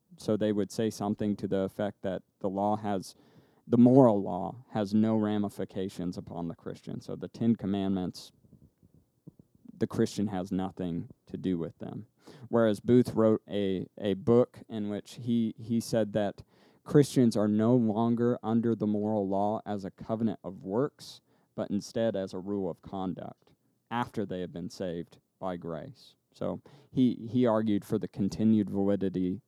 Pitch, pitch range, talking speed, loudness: 105 Hz, 95-115 Hz, 165 wpm, -30 LUFS